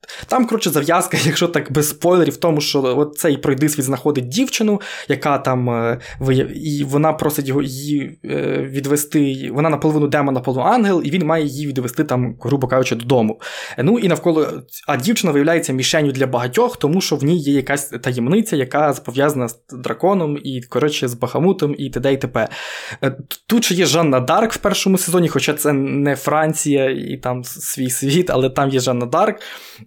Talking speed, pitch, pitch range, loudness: 180 wpm, 145 Hz, 130-165 Hz, -18 LUFS